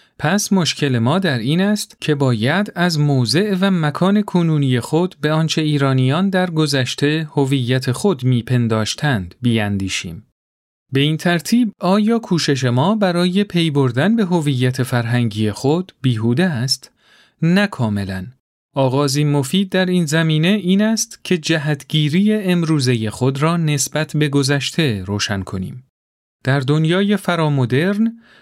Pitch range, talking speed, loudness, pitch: 125-180 Hz, 125 wpm, -17 LUFS, 150 Hz